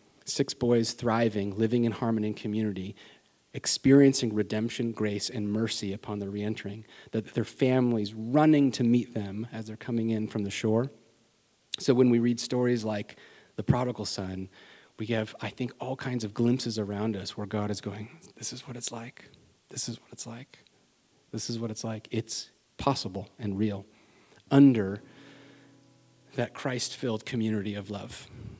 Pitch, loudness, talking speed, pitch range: 115 Hz, -29 LUFS, 165 wpm, 105-125 Hz